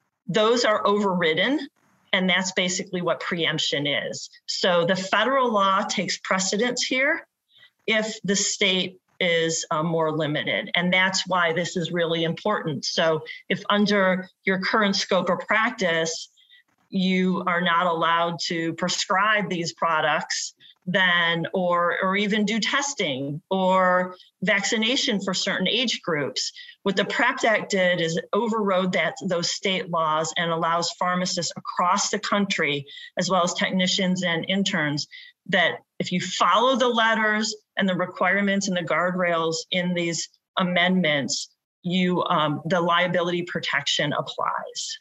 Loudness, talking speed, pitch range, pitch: -23 LUFS, 135 wpm, 170-205 Hz, 185 Hz